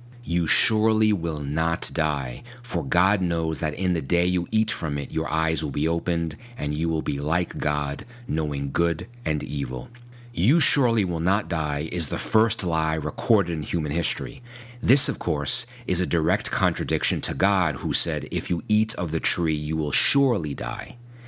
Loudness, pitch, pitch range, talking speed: -23 LUFS, 85 Hz, 80-110 Hz, 185 wpm